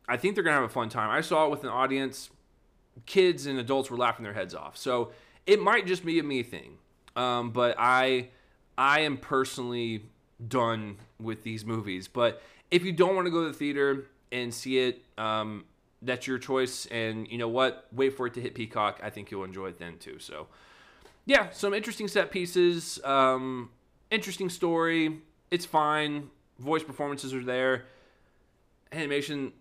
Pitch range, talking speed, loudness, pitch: 120-155 Hz, 180 wpm, -29 LUFS, 130 Hz